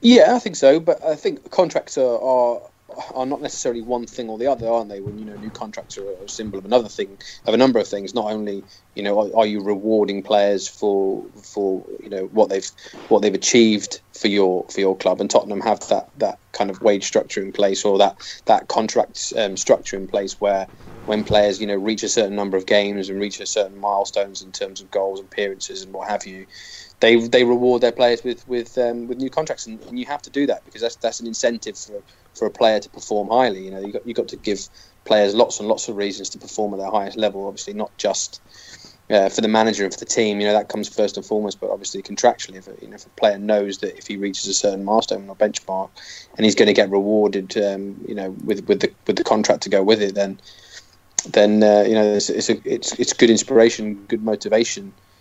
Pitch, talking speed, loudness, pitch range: 105 Hz, 240 wpm, -20 LUFS, 100-115 Hz